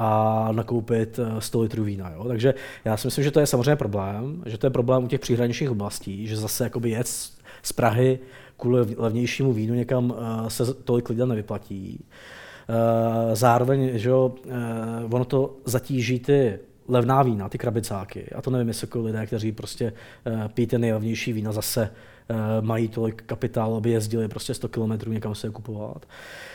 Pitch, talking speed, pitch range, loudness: 115 Hz, 160 wpm, 110-125 Hz, -25 LUFS